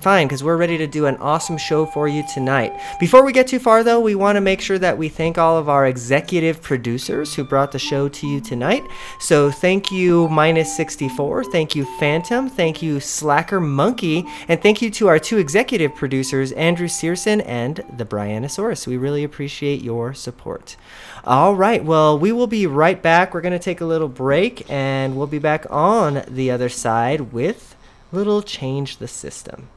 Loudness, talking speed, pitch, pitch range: -18 LUFS, 195 wpm, 155 Hz, 140-180 Hz